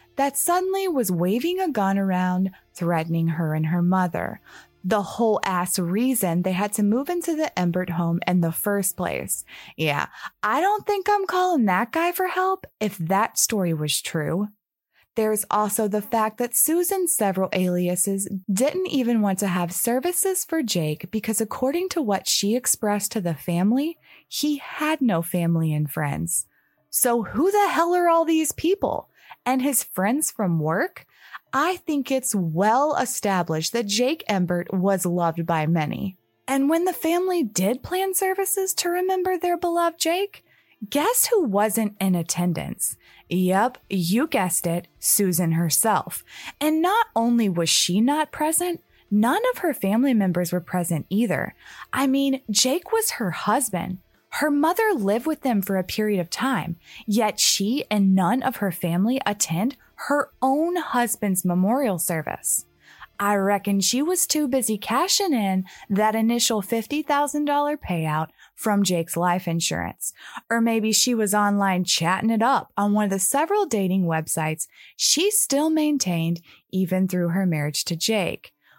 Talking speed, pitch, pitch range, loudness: 155 wpm, 215 Hz, 185-295 Hz, -23 LUFS